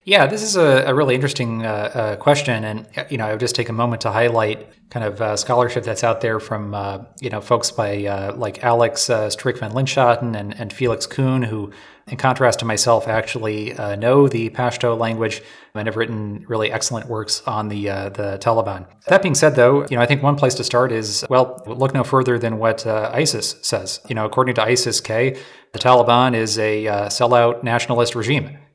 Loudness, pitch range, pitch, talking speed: -18 LUFS, 110-125 Hz, 115 Hz, 215 wpm